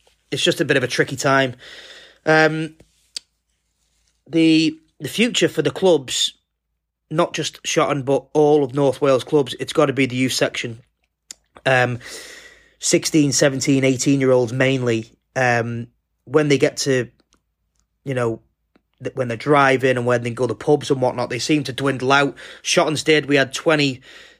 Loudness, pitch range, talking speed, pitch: -19 LUFS, 125-155 Hz, 165 wpm, 135 Hz